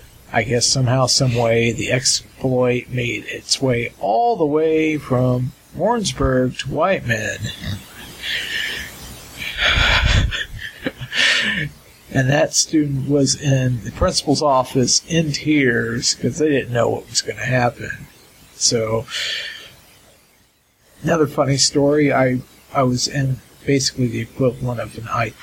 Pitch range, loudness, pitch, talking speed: 120-140 Hz, -18 LUFS, 130 Hz, 120 wpm